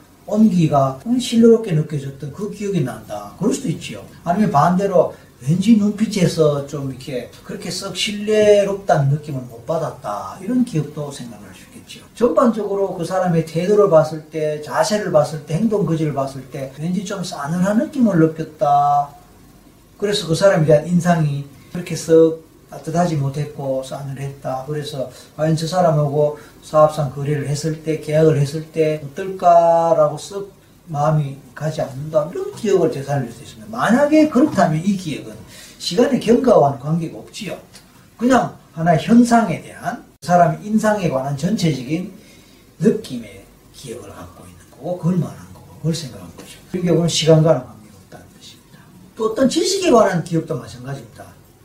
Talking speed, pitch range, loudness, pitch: 345 characters per minute, 140-195 Hz, -18 LUFS, 160 Hz